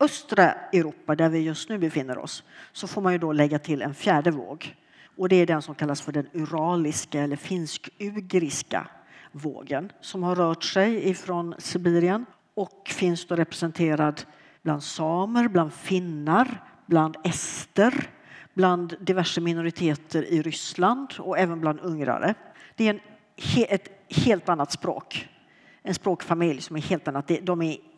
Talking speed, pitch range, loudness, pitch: 150 wpm, 155-190 Hz, -26 LUFS, 170 Hz